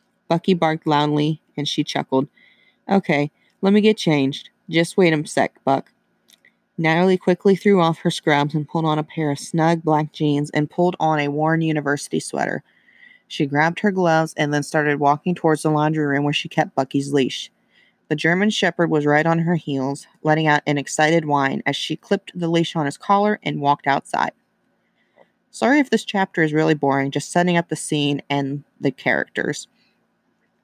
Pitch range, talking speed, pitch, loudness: 145-175 Hz, 185 wpm, 155 Hz, -20 LUFS